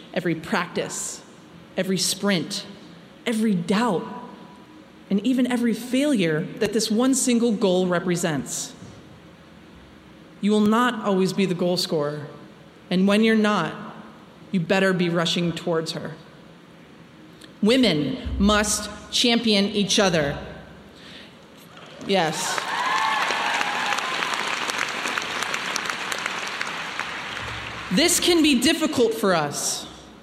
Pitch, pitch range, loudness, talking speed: 200 Hz, 180-230 Hz, -22 LUFS, 90 wpm